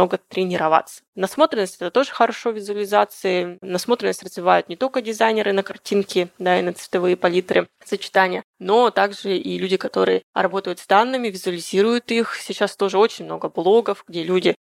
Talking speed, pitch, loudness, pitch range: 150 wpm, 195 Hz, -20 LUFS, 180-215 Hz